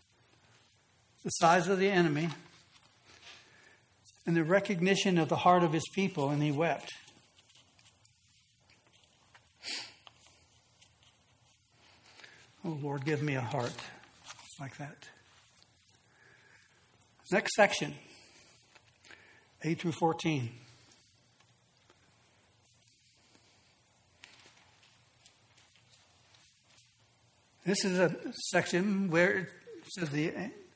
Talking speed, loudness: 75 wpm, -31 LUFS